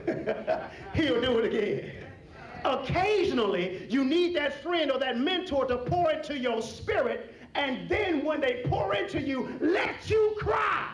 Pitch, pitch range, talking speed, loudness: 295 Hz, 255-345 Hz, 150 wpm, -28 LUFS